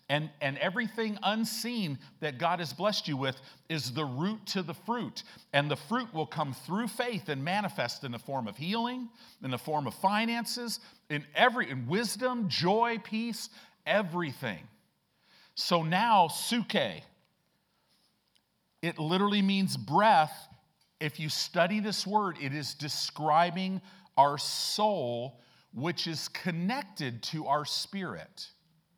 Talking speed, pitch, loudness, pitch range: 135 wpm, 180 Hz, -31 LUFS, 150-215 Hz